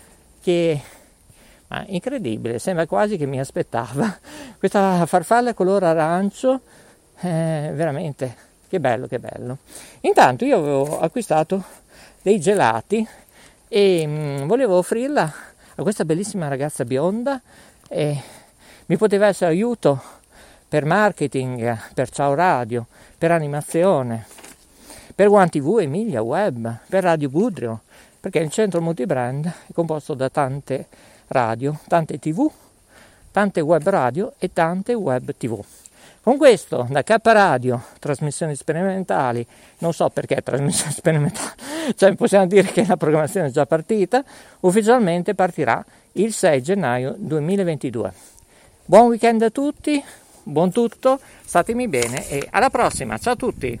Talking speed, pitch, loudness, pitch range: 125 wpm, 170 Hz, -20 LUFS, 145-205 Hz